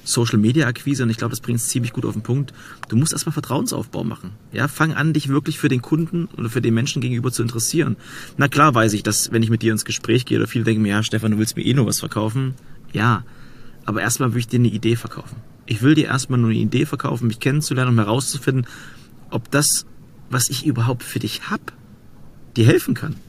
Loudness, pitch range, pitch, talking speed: -20 LUFS, 115-140 Hz, 125 Hz, 235 wpm